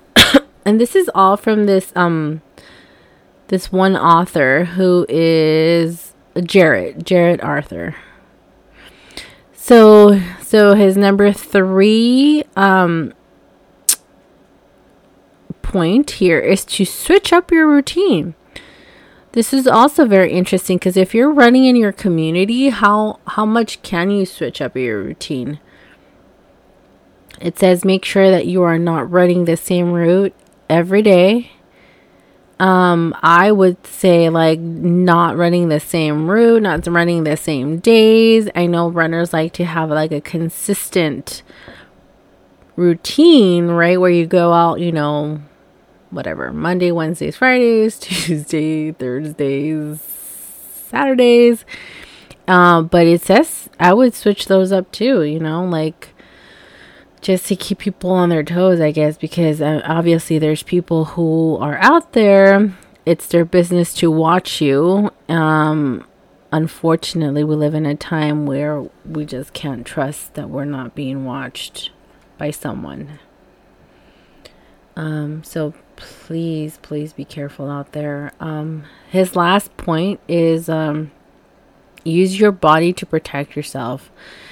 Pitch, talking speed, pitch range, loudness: 170 Hz, 130 wpm, 155-195 Hz, -14 LUFS